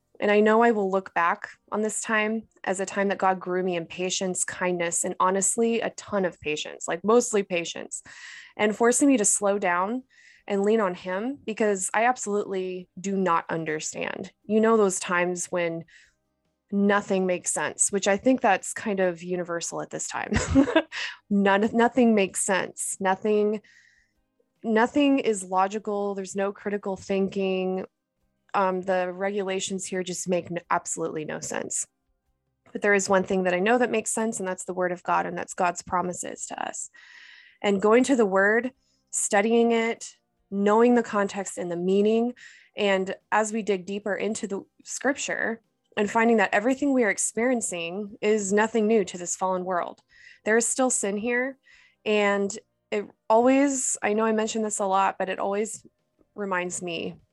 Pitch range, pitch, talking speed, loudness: 185-225 Hz, 200 Hz, 170 wpm, -25 LUFS